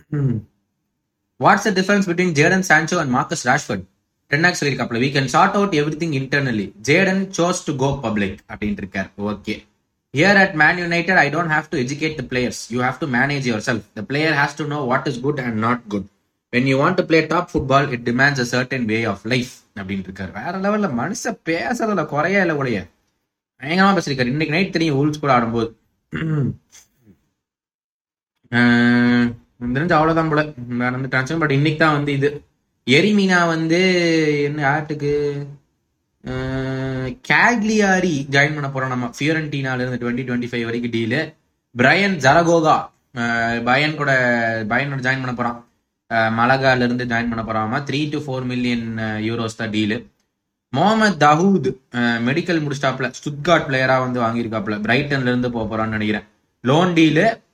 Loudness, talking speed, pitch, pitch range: -18 LUFS, 135 wpm, 135 Hz, 120-155 Hz